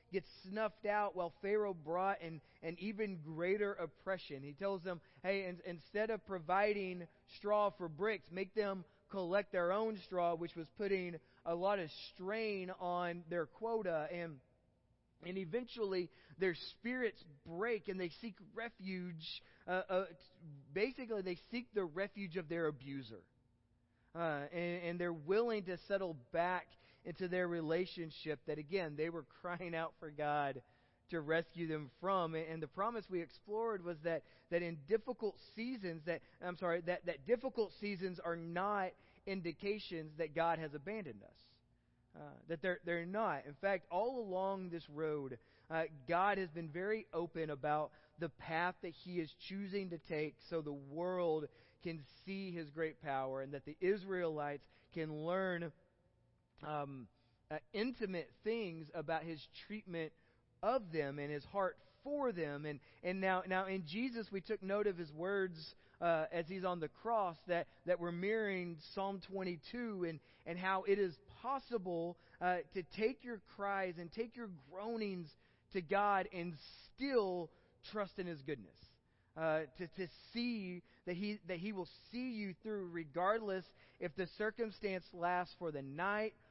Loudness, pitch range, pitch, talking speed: -42 LUFS, 160-200 Hz, 180 Hz, 160 wpm